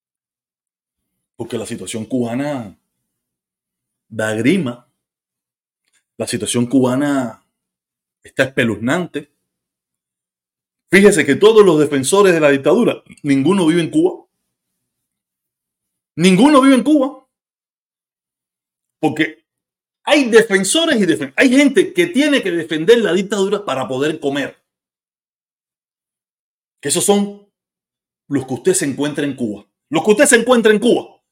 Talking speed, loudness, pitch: 115 wpm, -15 LUFS, 170 Hz